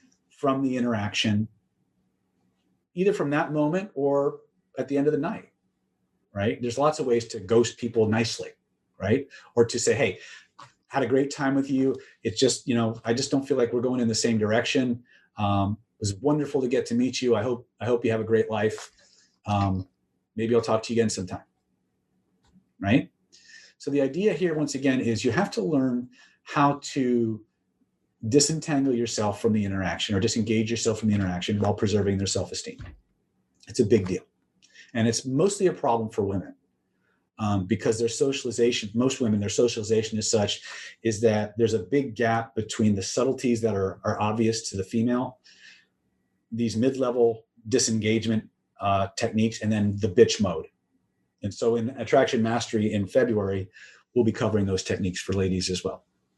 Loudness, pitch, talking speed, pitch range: -25 LUFS, 115 Hz, 180 wpm, 105-130 Hz